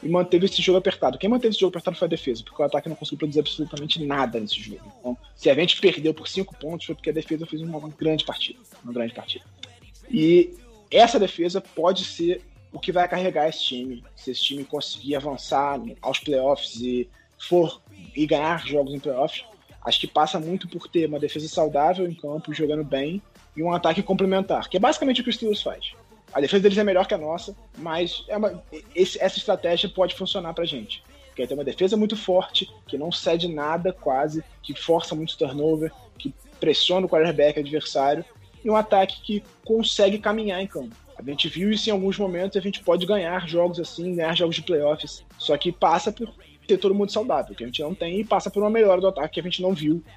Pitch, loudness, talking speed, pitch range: 170 Hz, -23 LUFS, 220 wpm, 150-190 Hz